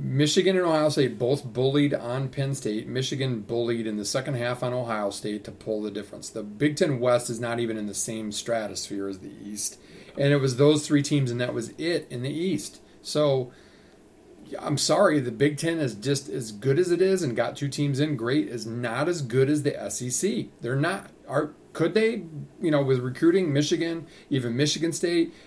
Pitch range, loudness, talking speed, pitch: 120-150 Hz, -26 LUFS, 205 wpm, 135 Hz